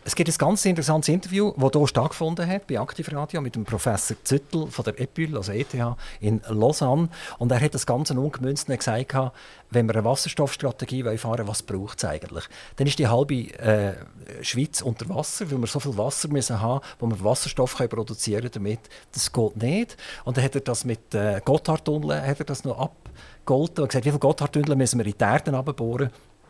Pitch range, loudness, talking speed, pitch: 115-150 Hz, -25 LUFS, 190 wpm, 130 Hz